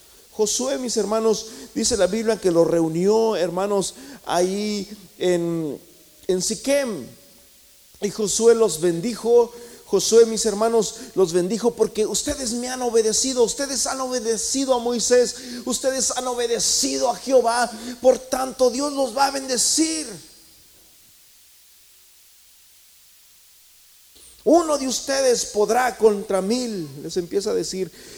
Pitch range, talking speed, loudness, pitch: 195-250 Hz, 115 wpm, -21 LUFS, 230 Hz